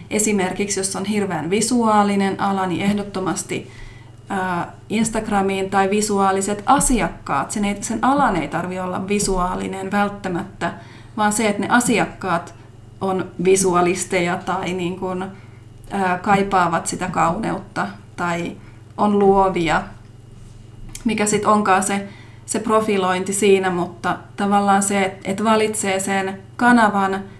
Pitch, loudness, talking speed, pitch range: 190 Hz, -19 LUFS, 105 wpm, 175-205 Hz